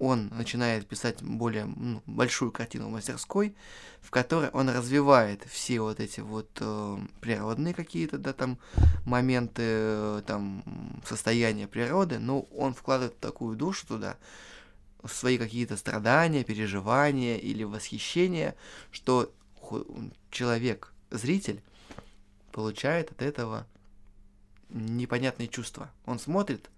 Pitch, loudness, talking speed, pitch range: 120 Hz, -30 LUFS, 110 wpm, 110-130 Hz